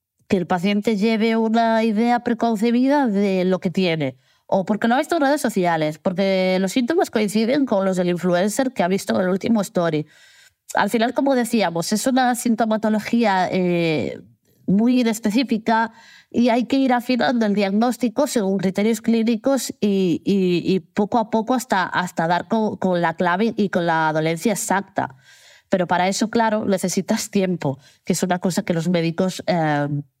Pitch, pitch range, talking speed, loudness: 210 Hz, 185-235 Hz, 170 wpm, -20 LUFS